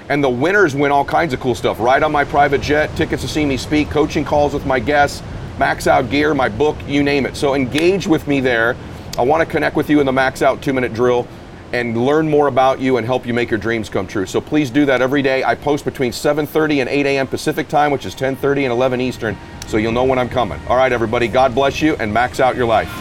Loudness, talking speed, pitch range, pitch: -16 LUFS, 260 wpm, 125-145 Hz, 135 Hz